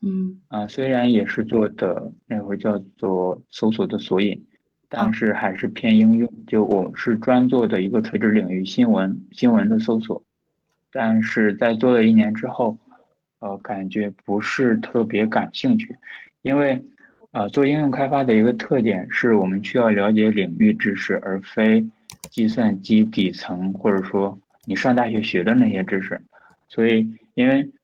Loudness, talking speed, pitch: -20 LUFS, 240 characters per minute, 120 Hz